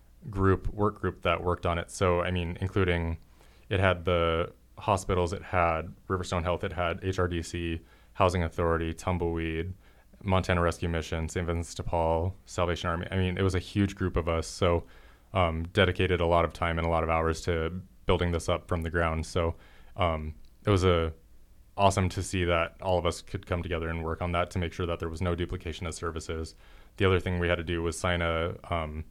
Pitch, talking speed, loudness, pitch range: 85 Hz, 210 wpm, -29 LUFS, 85-95 Hz